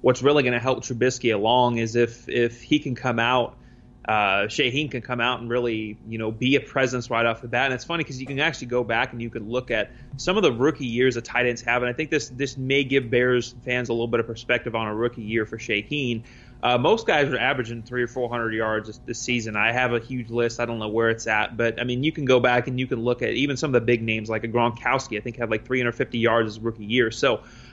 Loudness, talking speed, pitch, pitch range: -23 LUFS, 275 wpm, 120 Hz, 115-125 Hz